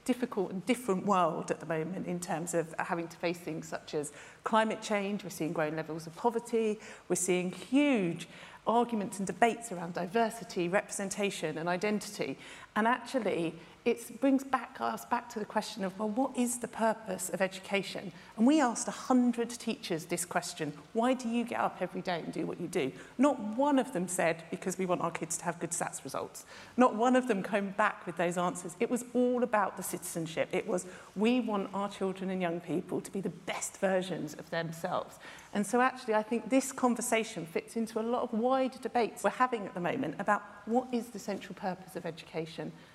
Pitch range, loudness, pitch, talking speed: 175-235 Hz, -33 LUFS, 200 Hz, 205 wpm